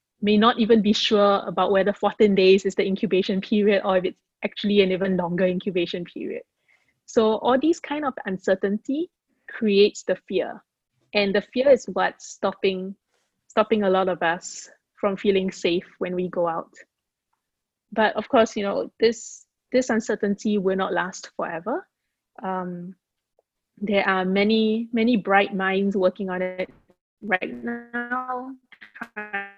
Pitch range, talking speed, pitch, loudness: 190-225 Hz, 150 wpm, 205 Hz, -23 LUFS